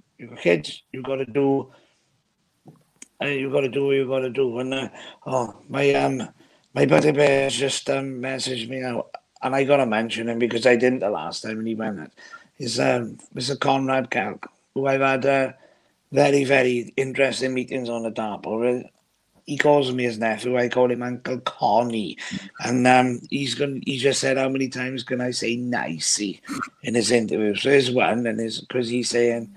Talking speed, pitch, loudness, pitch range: 195 wpm, 125 Hz, -22 LUFS, 120-135 Hz